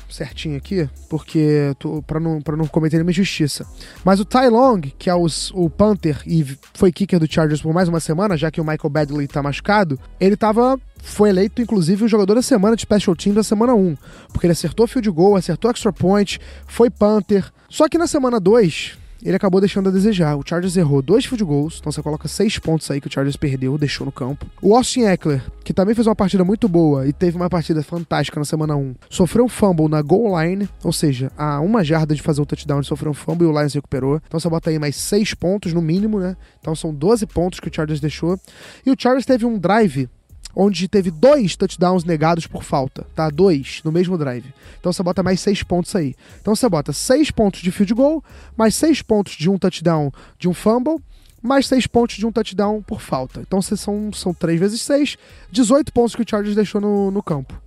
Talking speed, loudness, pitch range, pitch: 225 wpm, -18 LUFS, 155-210 Hz, 180 Hz